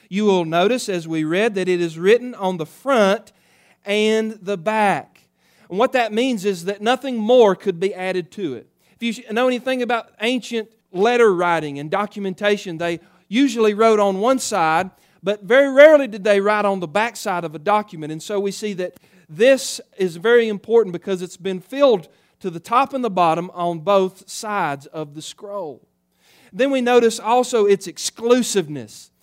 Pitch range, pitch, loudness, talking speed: 180-230 Hz, 205 Hz, -19 LUFS, 185 wpm